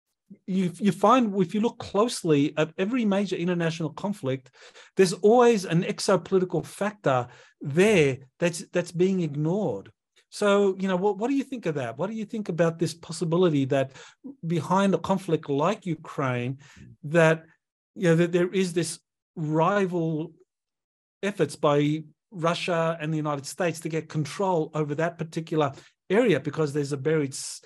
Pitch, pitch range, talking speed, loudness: 170 Hz, 155-195 Hz, 155 wpm, -25 LUFS